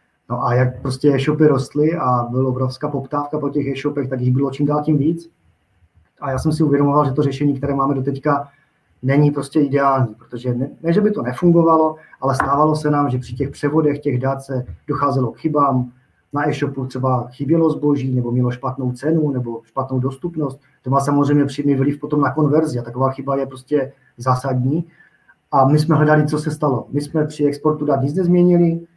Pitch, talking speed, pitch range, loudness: 140 Hz, 200 wpm, 130-150 Hz, -18 LUFS